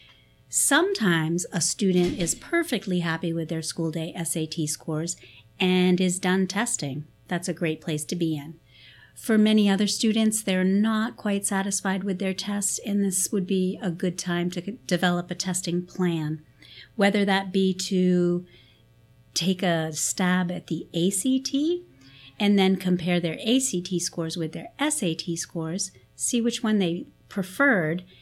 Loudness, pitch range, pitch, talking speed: -25 LUFS, 165-200 Hz, 180 Hz, 150 wpm